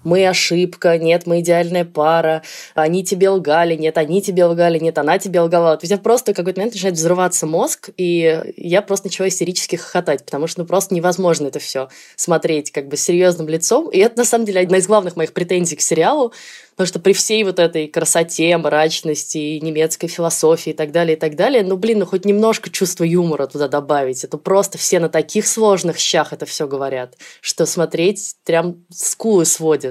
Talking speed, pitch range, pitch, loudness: 195 wpm, 160-190 Hz, 170 Hz, -16 LUFS